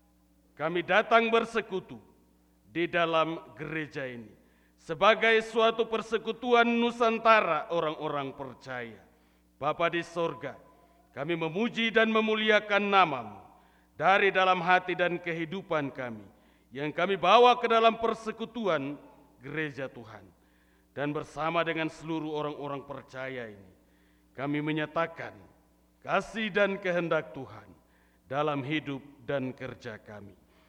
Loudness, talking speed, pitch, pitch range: -28 LUFS, 105 wpm, 155 Hz, 125-195 Hz